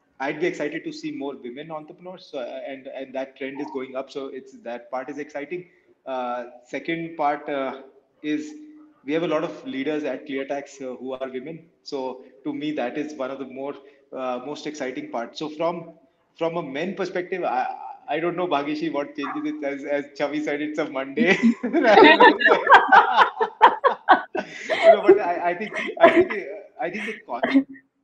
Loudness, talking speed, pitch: -22 LUFS, 195 wpm, 155 Hz